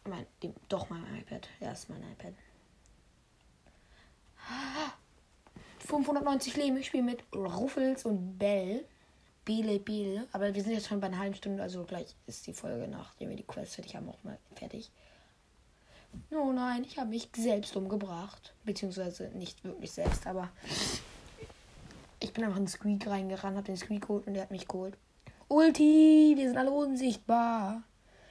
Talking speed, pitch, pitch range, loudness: 160 wpm, 210 Hz, 195-260 Hz, -32 LUFS